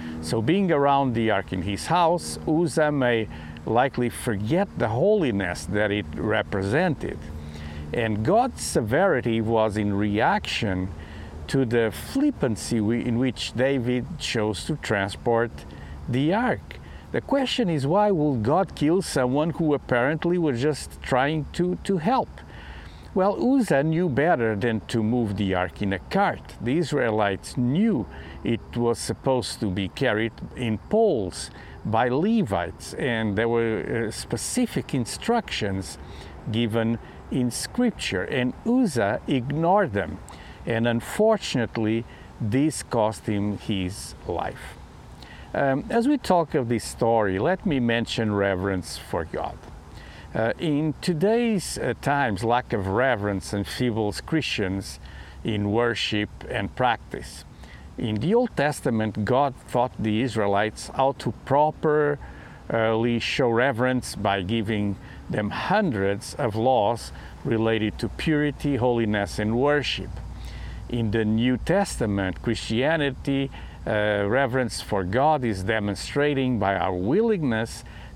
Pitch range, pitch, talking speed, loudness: 100-145 Hz, 115 Hz, 125 wpm, -24 LUFS